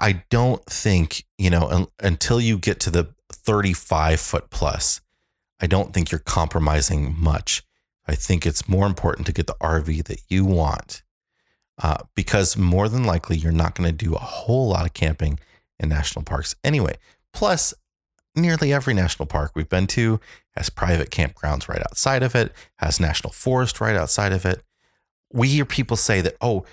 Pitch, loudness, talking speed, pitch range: 90 Hz, -21 LUFS, 175 wpm, 80-105 Hz